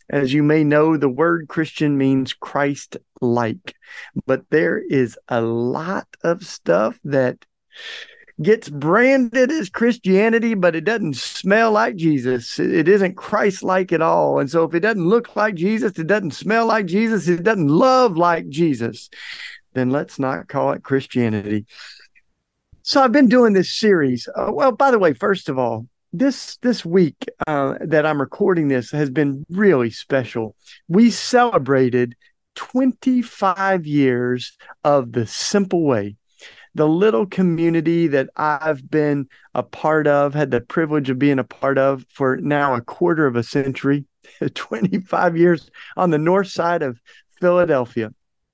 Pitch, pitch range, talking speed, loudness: 160 Hz, 135-205 Hz, 155 wpm, -18 LUFS